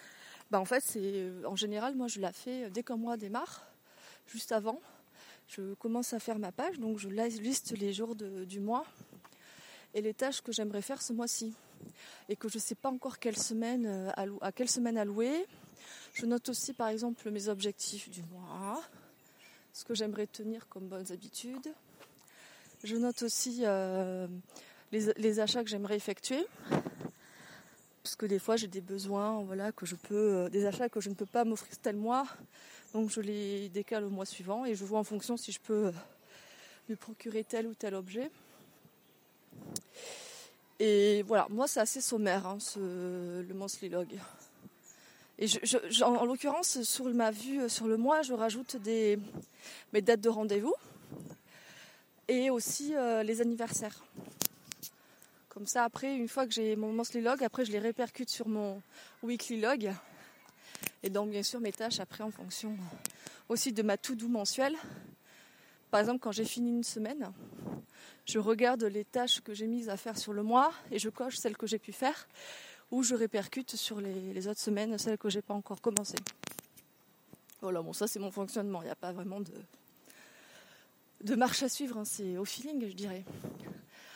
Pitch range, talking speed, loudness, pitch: 205-240 Hz, 175 wpm, -35 LUFS, 220 Hz